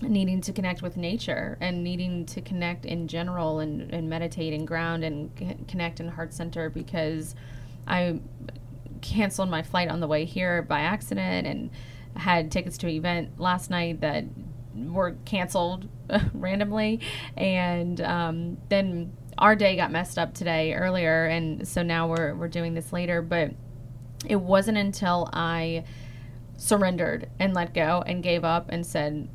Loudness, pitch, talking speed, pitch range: -27 LUFS, 170 Hz, 155 wpm, 155-180 Hz